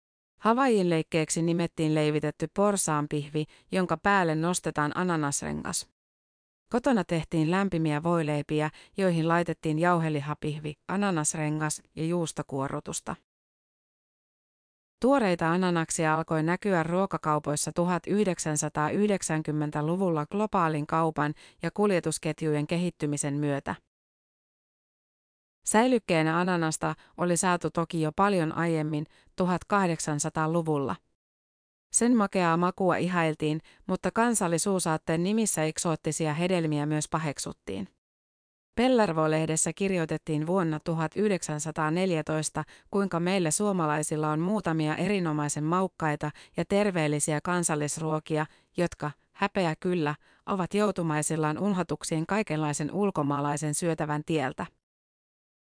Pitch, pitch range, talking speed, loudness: 160 Hz, 155-180 Hz, 80 wpm, -28 LUFS